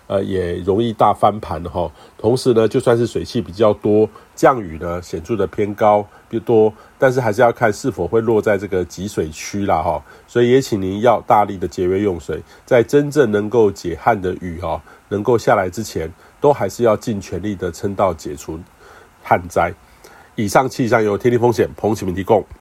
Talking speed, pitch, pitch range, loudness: 285 characters per minute, 105 Hz, 95-120 Hz, -17 LUFS